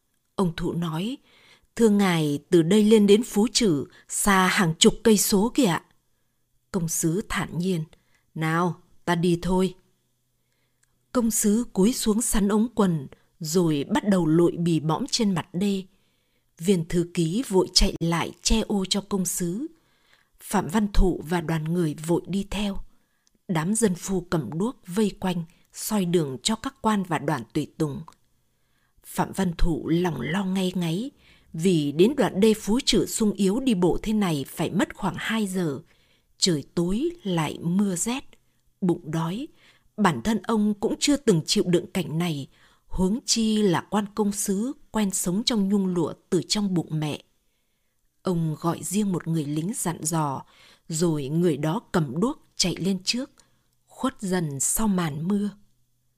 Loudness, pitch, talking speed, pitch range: -24 LUFS, 185 Hz, 165 wpm, 165-215 Hz